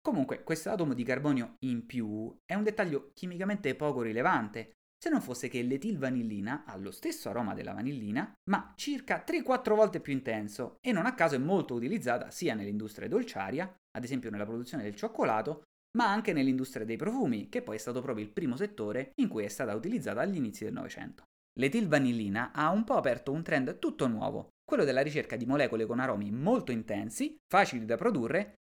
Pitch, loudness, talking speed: 135 Hz, -33 LUFS, 185 wpm